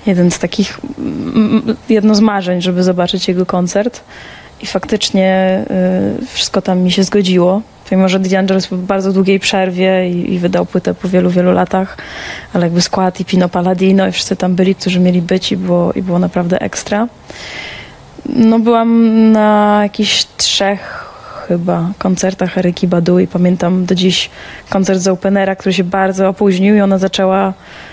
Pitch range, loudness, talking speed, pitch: 185-205 Hz, -12 LUFS, 165 wpm, 190 Hz